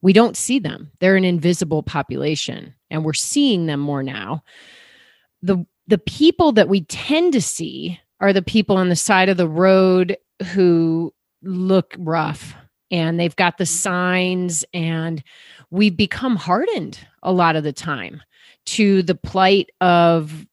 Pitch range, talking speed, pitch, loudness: 165-195 Hz, 150 wpm, 180 Hz, -18 LUFS